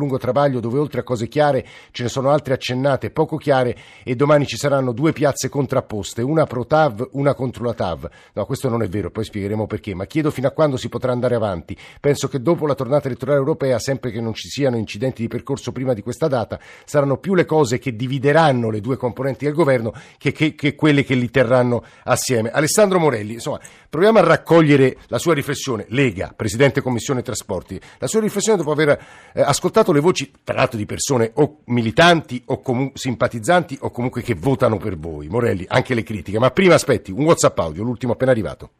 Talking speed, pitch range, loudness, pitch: 205 wpm, 115-145 Hz, -19 LUFS, 130 Hz